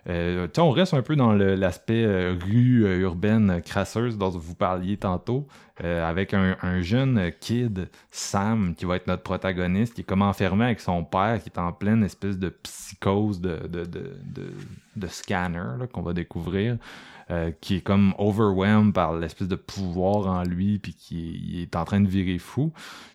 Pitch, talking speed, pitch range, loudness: 95 Hz, 185 wpm, 90-105 Hz, -25 LUFS